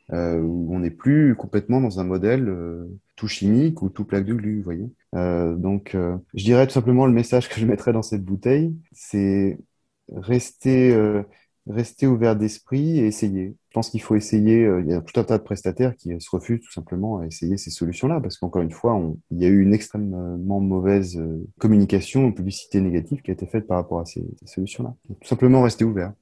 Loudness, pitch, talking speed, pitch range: -21 LUFS, 105 Hz, 215 wpm, 90-120 Hz